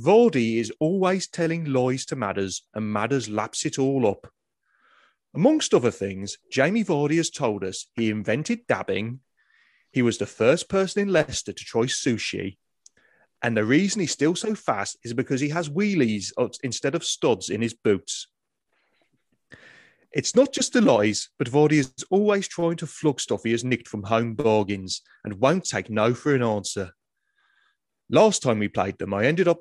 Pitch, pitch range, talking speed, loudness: 135 Hz, 110-180 Hz, 175 wpm, -24 LUFS